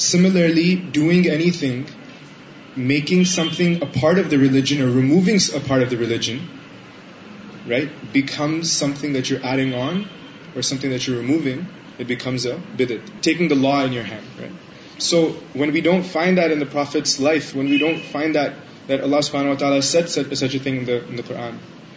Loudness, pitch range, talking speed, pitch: -19 LUFS, 135-165 Hz, 150 wpm, 145 Hz